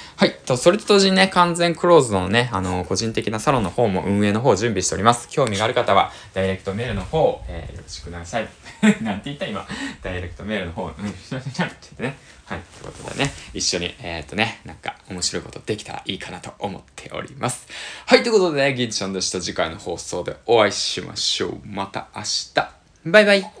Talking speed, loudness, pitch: 445 characters per minute, -21 LUFS, 110 Hz